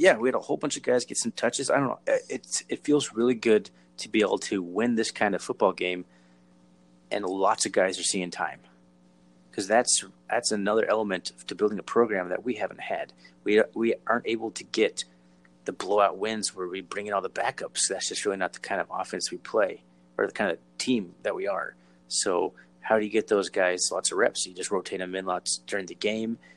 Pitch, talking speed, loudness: 90 Hz, 230 wpm, -27 LUFS